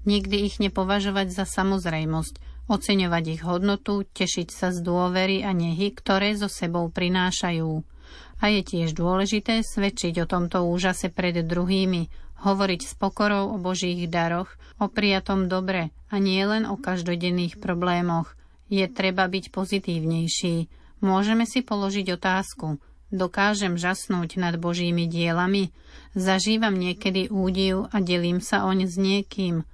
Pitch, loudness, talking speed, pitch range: 190 Hz, -25 LUFS, 130 wpm, 175-200 Hz